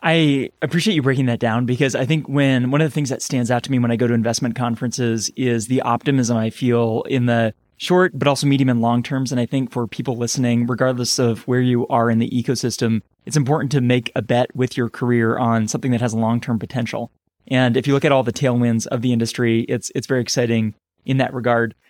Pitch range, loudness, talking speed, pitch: 120-135 Hz, -19 LUFS, 240 wpm, 125 Hz